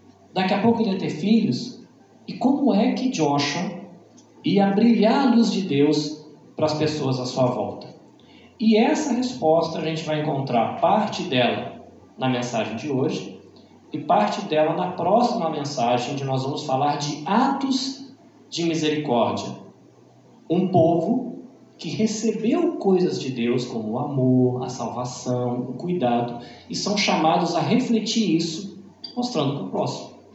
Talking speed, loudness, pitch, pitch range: 150 wpm, -22 LUFS, 165 Hz, 135-220 Hz